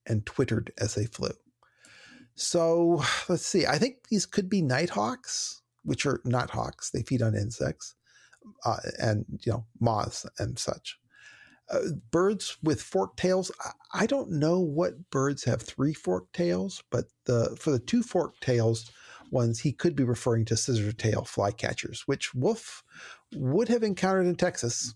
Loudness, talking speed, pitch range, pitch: -29 LUFS, 160 wpm, 115-180 Hz, 140 Hz